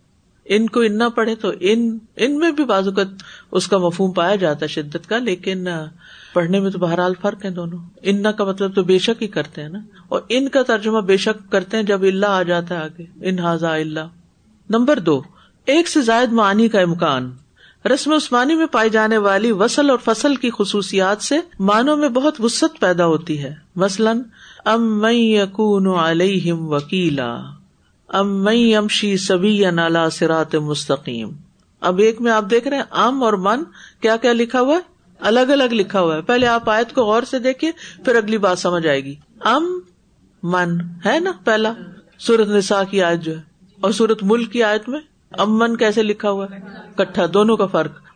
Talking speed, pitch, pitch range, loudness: 190 wpm, 205 Hz, 180-230 Hz, -17 LUFS